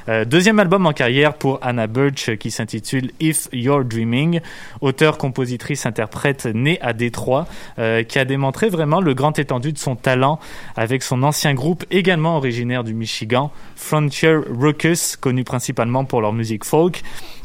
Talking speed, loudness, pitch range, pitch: 145 wpm, -18 LUFS, 120-155 Hz, 135 Hz